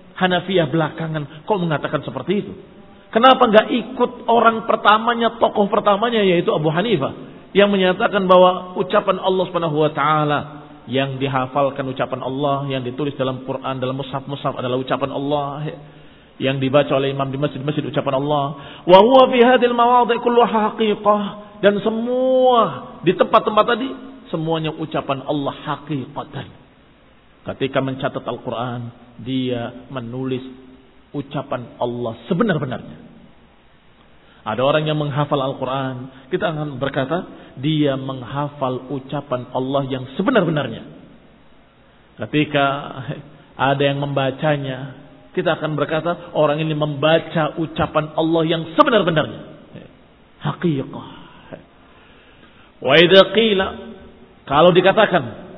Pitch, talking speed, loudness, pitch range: 150 Hz, 105 wpm, -18 LUFS, 135-190 Hz